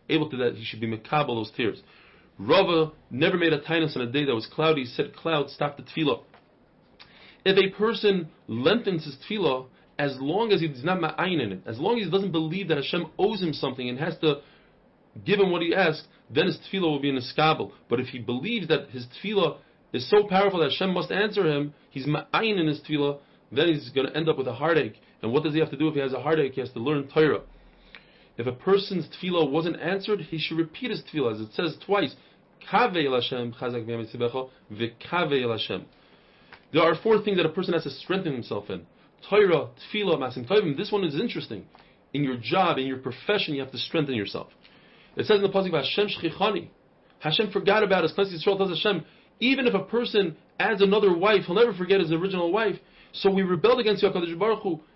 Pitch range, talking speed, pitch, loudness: 140-195 Hz, 205 wpm, 160 Hz, -25 LUFS